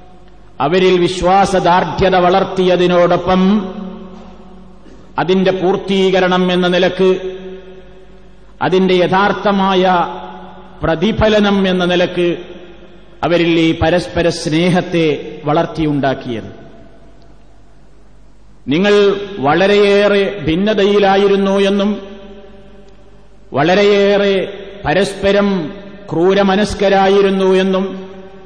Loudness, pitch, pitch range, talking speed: -13 LUFS, 185 Hz, 175-195 Hz, 55 wpm